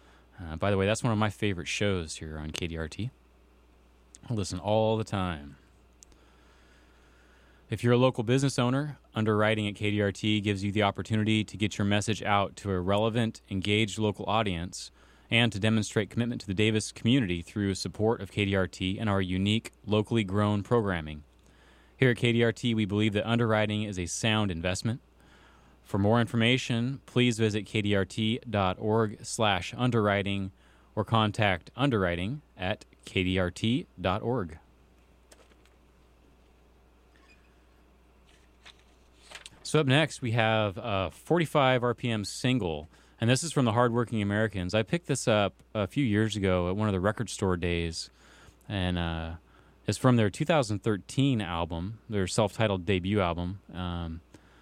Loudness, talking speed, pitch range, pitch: -28 LUFS, 140 wpm, 85-110 Hz, 100 Hz